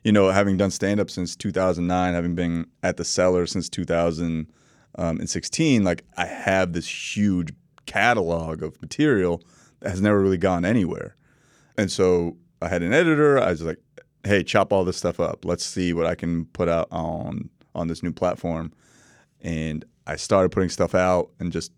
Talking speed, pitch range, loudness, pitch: 175 wpm, 85-95 Hz, -23 LUFS, 90 Hz